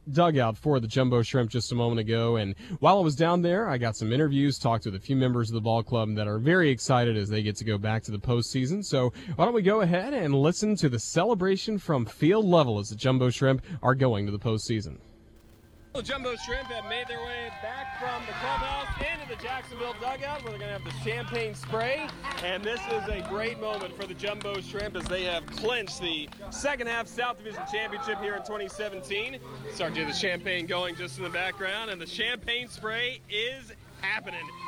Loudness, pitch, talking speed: -28 LUFS, 165 Hz, 220 wpm